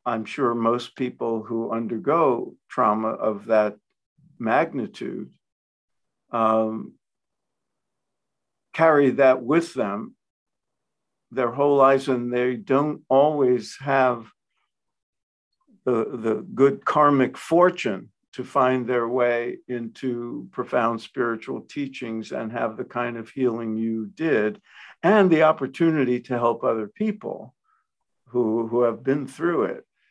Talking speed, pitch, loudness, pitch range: 115 wpm, 125 Hz, -23 LUFS, 115-140 Hz